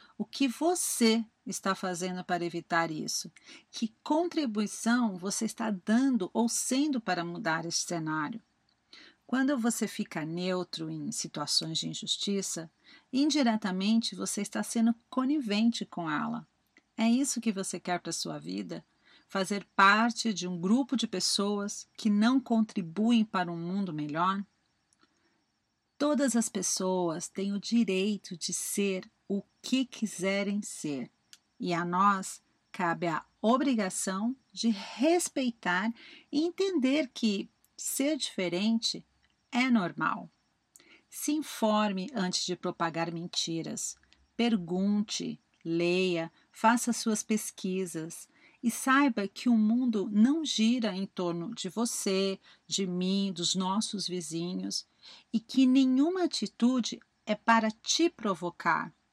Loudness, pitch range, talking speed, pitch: -30 LUFS, 185-235 Hz, 120 wpm, 210 Hz